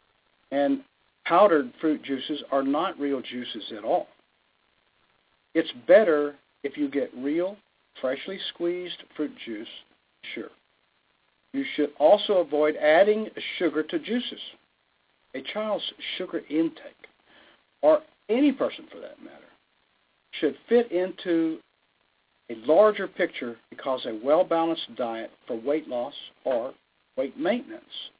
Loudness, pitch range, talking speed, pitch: -26 LUFS, 140-200 Hz, 115 wpm, 160 Hz